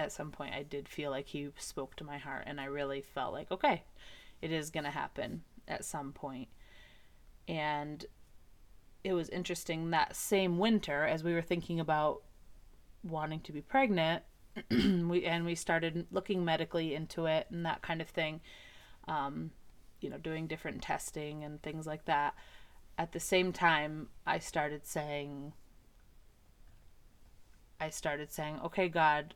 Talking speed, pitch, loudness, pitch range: 155 wpm, 155 Hz, -36 LUFS, 150-170 Hz